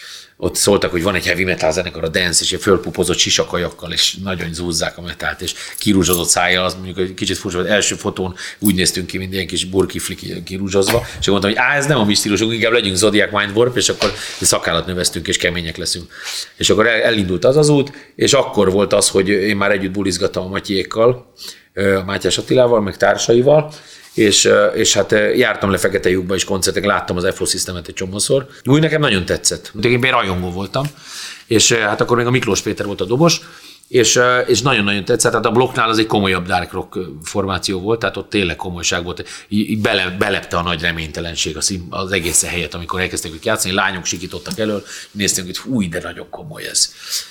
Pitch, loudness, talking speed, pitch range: 95 Hz, -16 LUFS, 195 wpm, 90-110 Hz